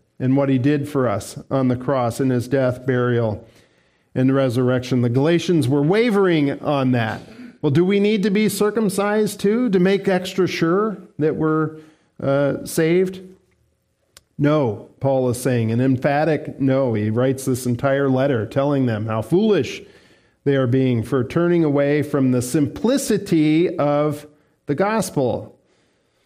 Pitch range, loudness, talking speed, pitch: 130-175 Hz, -19 LUFS, 150 wpm, 145 Hz